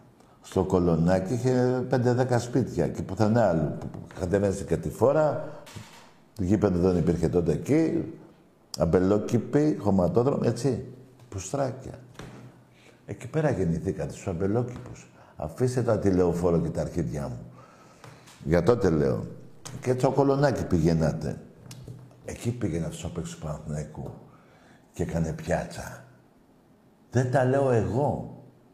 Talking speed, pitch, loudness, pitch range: 115 wpm, 105 Hz, -26 LUFS, 90-125 Hz